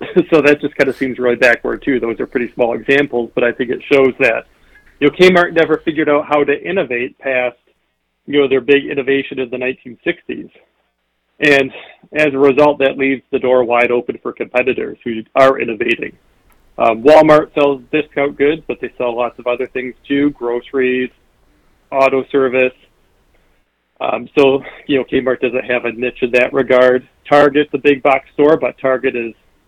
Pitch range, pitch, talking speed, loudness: 125-145 Hz, 135 Hz, 180 wpm, -14 LUFS